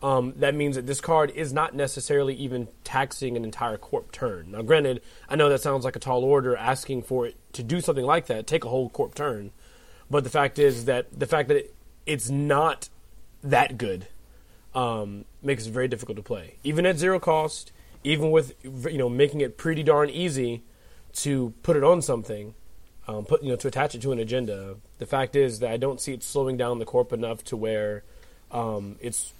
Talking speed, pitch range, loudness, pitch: 205 wpm, 115-145 Hz, -26 LUFS, 130 Hz